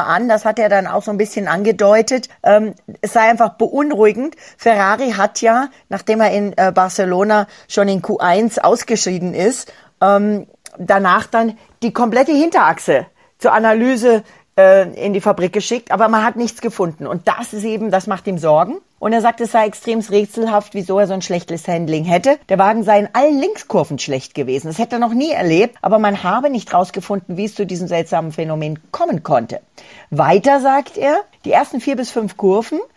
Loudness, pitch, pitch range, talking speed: -15 LUFS, 210 Hz, 190-230 Hz, 180 wpm